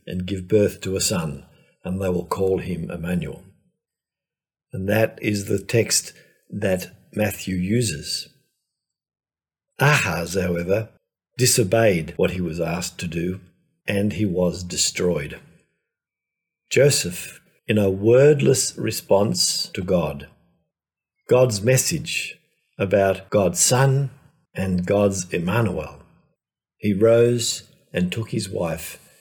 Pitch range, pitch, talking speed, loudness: 90-120 Hz, 100 Hz, 110 wpm, -21 LUFS